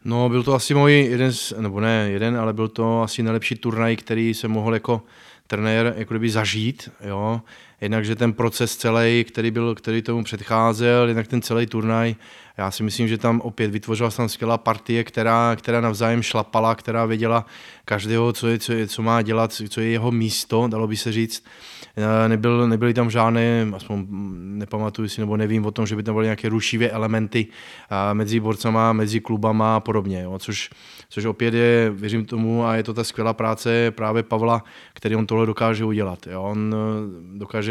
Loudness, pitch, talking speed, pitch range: -21 LUFS, 115 Hz, 185 wpm, 110-115 Hz